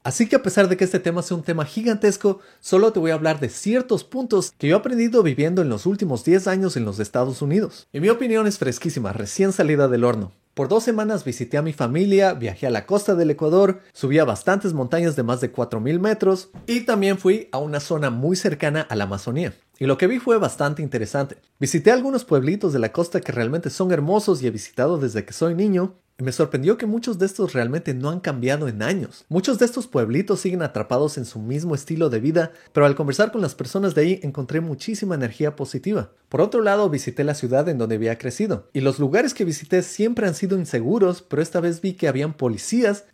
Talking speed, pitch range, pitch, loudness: 225 wpm, 140-195 Hz, 170 Hz, -21 LUFS